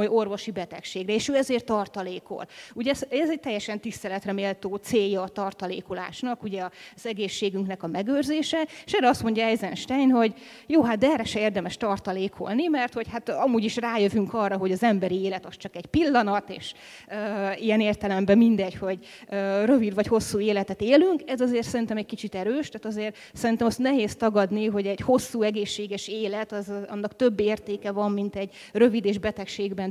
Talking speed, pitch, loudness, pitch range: 175 wpm, 210 Hz, -26 LUFS, 200-235 Hz